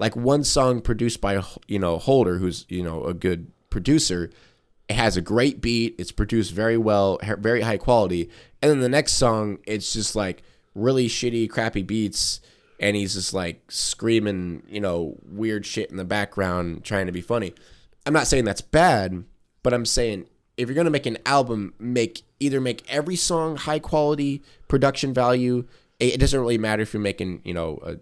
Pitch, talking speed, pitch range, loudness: 110 Hz, 195 wpm, 100-125 Hz, -23 LUFS